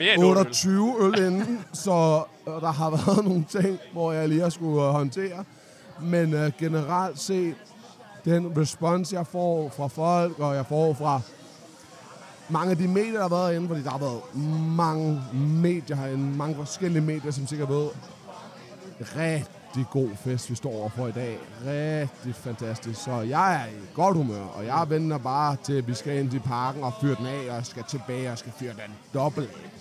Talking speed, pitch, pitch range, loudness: 180 wpm, 150 Hz, 135-170 Hz, -26 LUFS